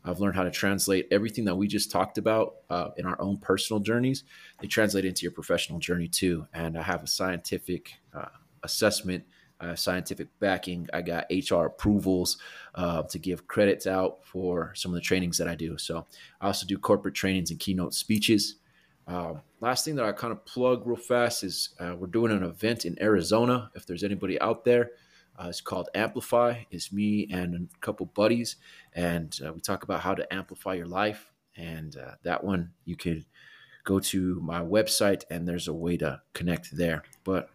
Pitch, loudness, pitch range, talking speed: 95 Hz, -29 LUFS, 85-105 Hz, 195 wpm